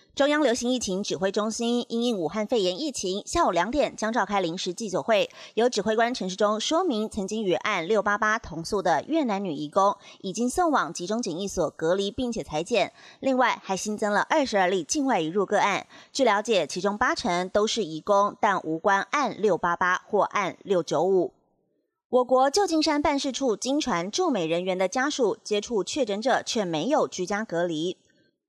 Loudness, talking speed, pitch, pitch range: -25 LUFS, 265 characters per minute, 215 Hz, 195-260 Hz